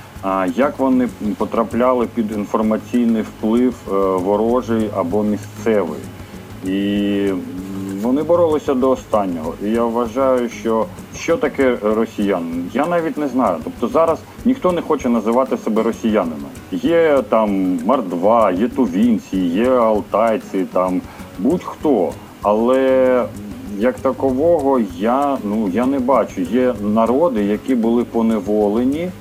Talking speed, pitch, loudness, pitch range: 115 wpm, 115 Hz, -18 LUFS, 105-130 Hz